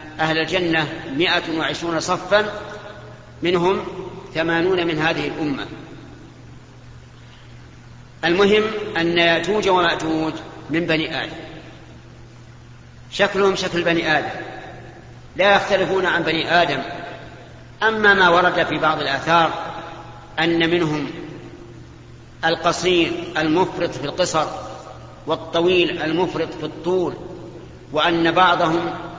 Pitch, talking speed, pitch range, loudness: 165 Hz, 90 wpm, 155-180 Hz, -19 LUFS